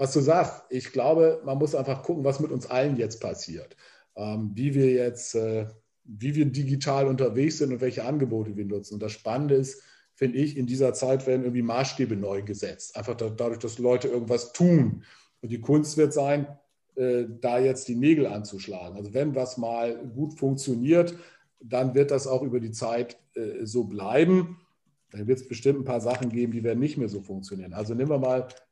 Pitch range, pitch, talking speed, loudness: 115-140 Hz, 130 Hz, 190 wpm, -26 LUFS